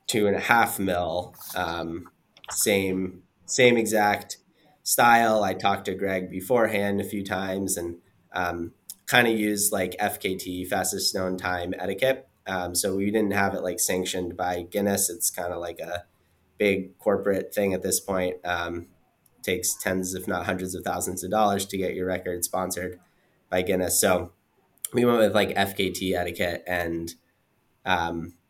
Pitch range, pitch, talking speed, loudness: 90-100 Hz, 95 Hz, 160 wpm, -25 LUFS